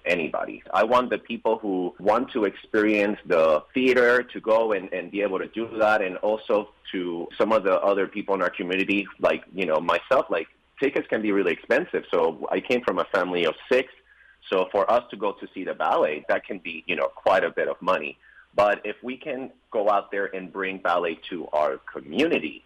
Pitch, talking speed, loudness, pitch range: 105 Hz, 215 wpm, -24 LUFS, 100-125 Hz